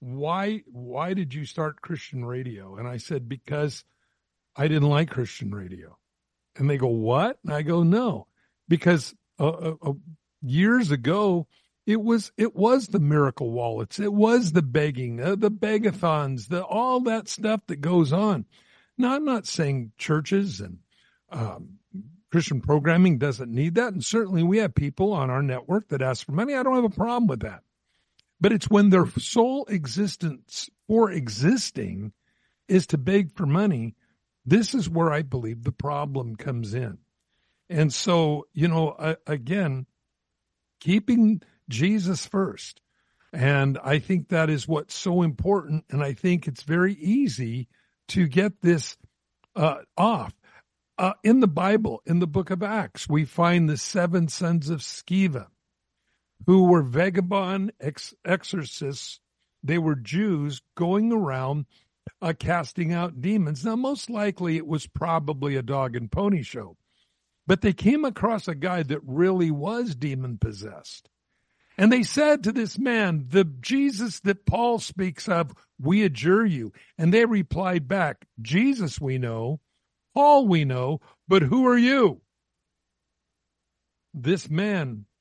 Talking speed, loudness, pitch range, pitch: 150 wpm, -24 LUFS, 140-200 Hz, 170 Hz